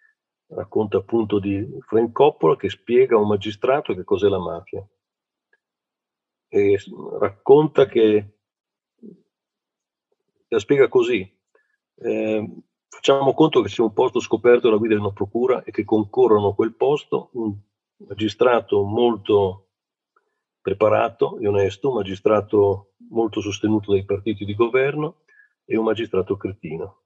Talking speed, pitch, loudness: 125 wpm, 130 Hz, -20 LUFS